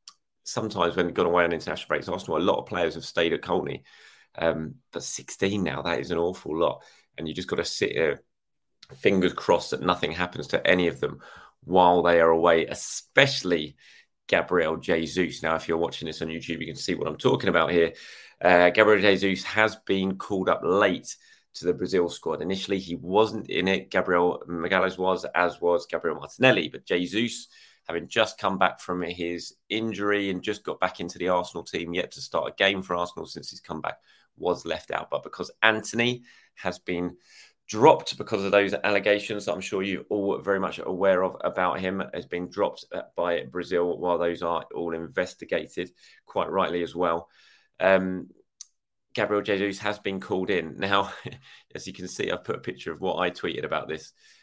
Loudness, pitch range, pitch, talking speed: -26 LUFS, 85-100 Hz, 90 Hz, 190 wpm